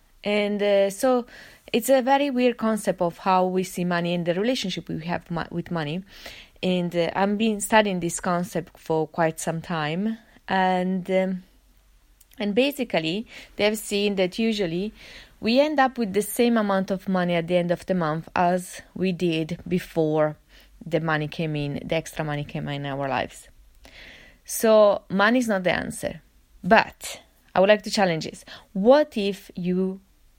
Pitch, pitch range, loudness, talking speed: 185 Hz, 170-210 Hz, -24 LUFS, 165 wpm